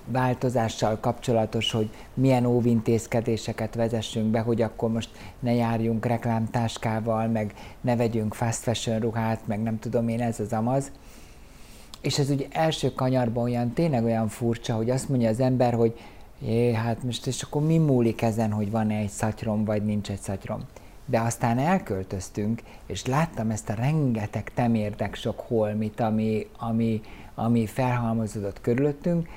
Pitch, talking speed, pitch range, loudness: 115 Hz, 145 wpm, 110-125 Hz, -26 LUFS